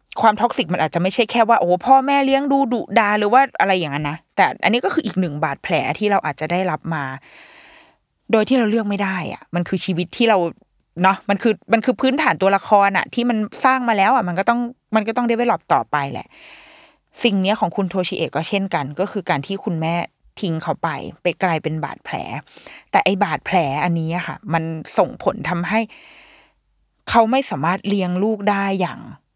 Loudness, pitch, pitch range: -19 LUFS, 200 Hz, 175-235 Hz